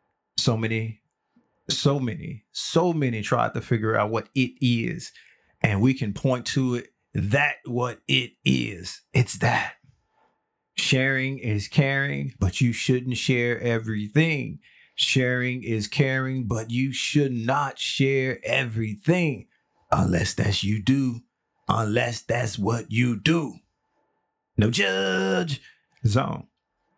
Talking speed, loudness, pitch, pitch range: 120 wpm, -24 LUFS, 120 Hz, 110-135 Hz